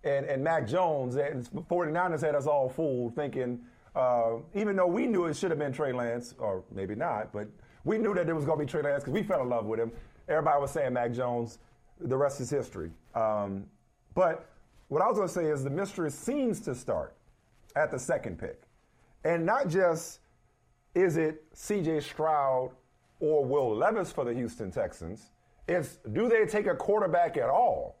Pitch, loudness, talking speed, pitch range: 145 Hz, -30 LUFS, 195 wpm, 120-170 Hz